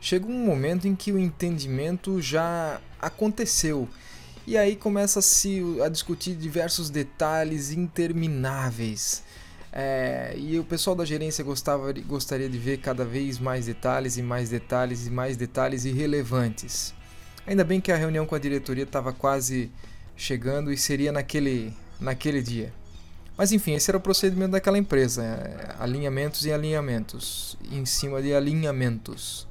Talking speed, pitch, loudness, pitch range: 140 wpm, 140 Hz, -26 LUFS, 125-165 Hz